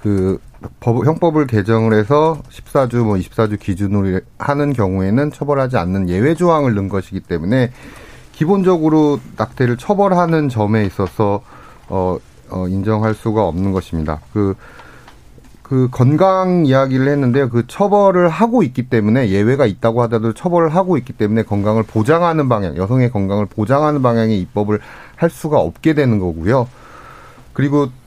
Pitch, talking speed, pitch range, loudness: 120 Hz, 325 characters per minute, 105-145 Hz, -16 LUFS